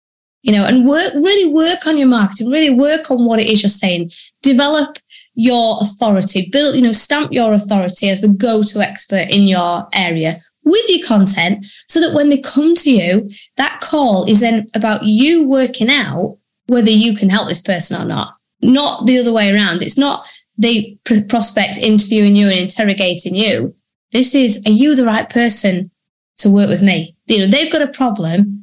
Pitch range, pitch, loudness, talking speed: 200-270 Hz, 220 Hz, -13 LUFS, 190 wpm